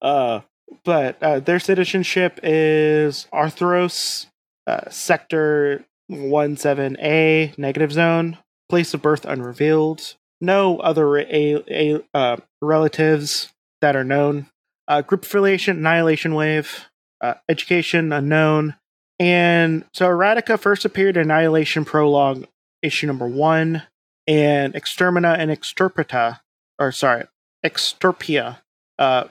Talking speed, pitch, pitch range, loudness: 110 wpm, 155 Hz, 150-170 Hz, -19 LUFS